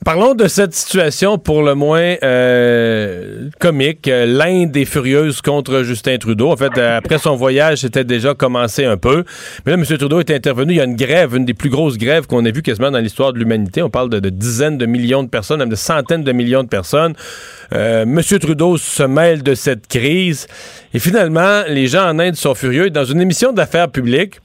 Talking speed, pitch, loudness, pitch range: 210 wpm, 140 Hz, -14 LUFS, 125-165 Hz